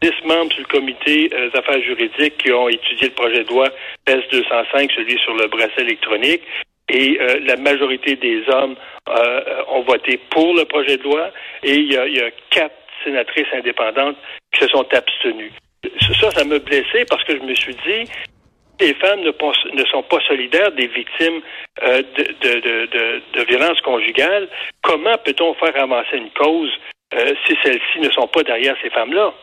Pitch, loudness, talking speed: 165 Hz, -16 LUFS, 180 wpm